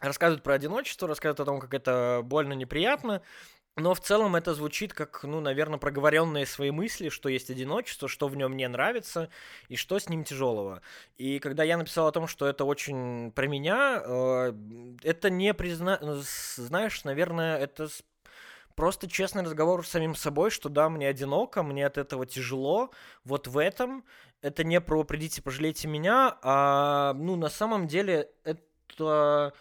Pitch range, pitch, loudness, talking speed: 140-170 Hz, 150 Hz, -29 LUFS, 160 wpm